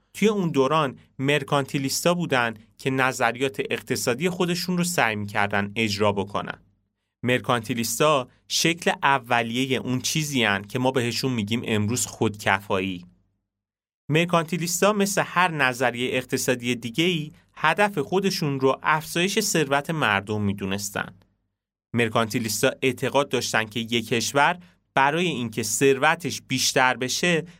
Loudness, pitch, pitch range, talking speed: -23 LUFS, 130 Hz, 110-155 Hz, 110 wpm